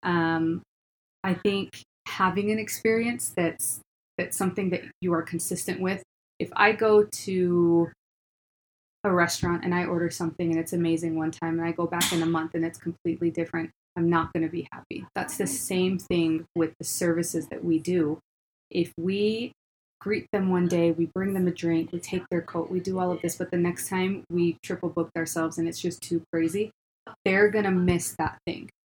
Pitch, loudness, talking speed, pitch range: 175 Hz, -27 LUFS, 195 wpm, 165-185 Hz